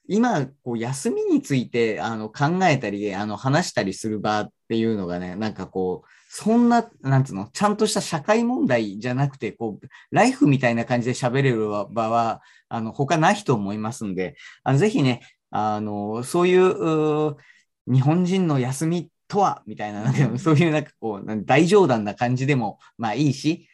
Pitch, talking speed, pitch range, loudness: 130 Hz, 340 characters per minute, 110-160 Hz, -22 LUFS